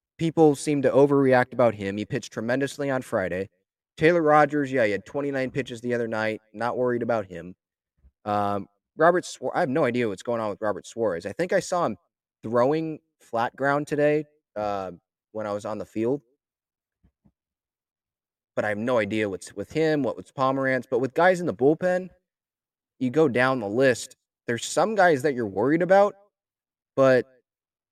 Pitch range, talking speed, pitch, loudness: 110-150 Hz, 180 wpm, 125 Hz, -24 LUFS